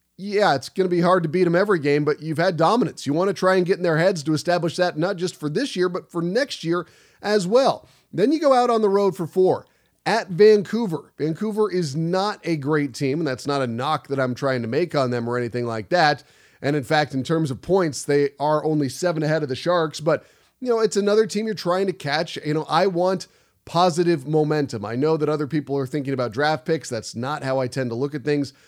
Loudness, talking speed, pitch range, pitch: -22 LUFS, 255 wpm, 140-185 Hz, 160 Hz